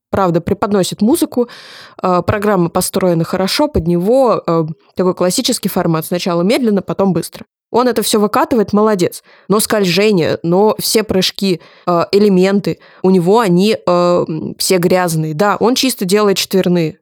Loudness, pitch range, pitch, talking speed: -14 LUFS, 175-215 Hz, 190 Hz, 125 wpm